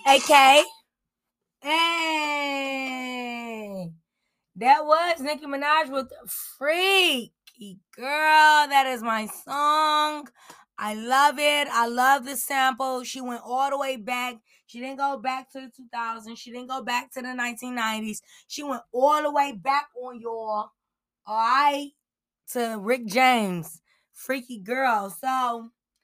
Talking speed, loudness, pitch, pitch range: 130 wpm, -23 LUFS, 260 Hz, 235-285 Hz